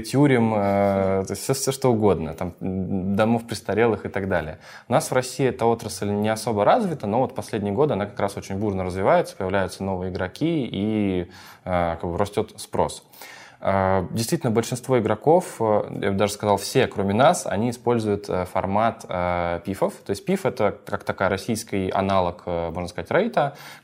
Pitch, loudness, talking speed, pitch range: 100 Hz, -23 LUFS, 165 wpm, 95-115 Hz